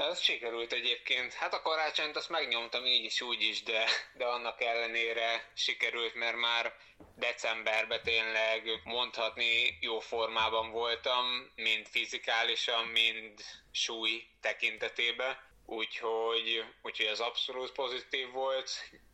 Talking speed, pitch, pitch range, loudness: 115 wpm, 115 Hz, 115-125 Hz, -32 LUFS